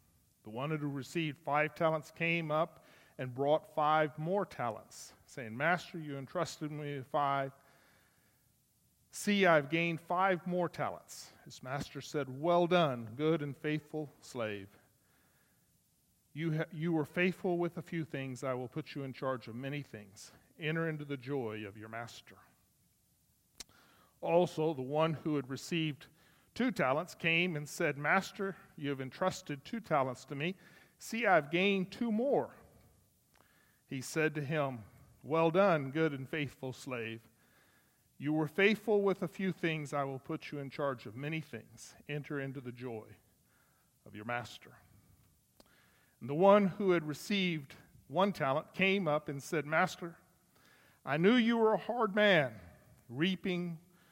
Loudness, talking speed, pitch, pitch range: -34 LUFS, 155 wpm, 150 Hz, 135-175 Hz